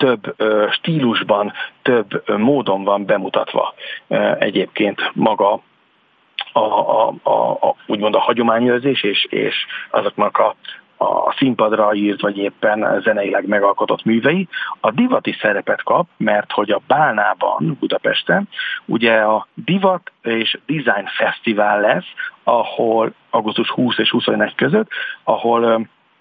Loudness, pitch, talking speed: -17 LUFS, 120 Hz, 110 wpm